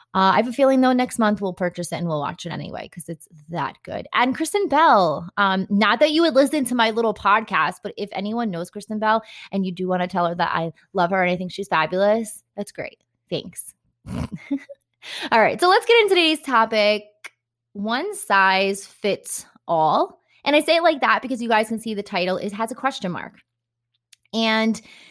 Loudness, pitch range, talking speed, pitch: -20 LUFS, 185-255 Hz, 215 wpm, 210 Hz